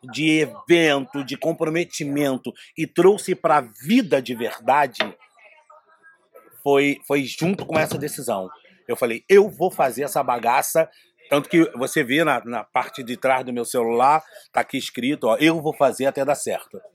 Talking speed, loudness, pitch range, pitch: 165 wpm, -21 LUFS, 140-170 Hz, 155 Hz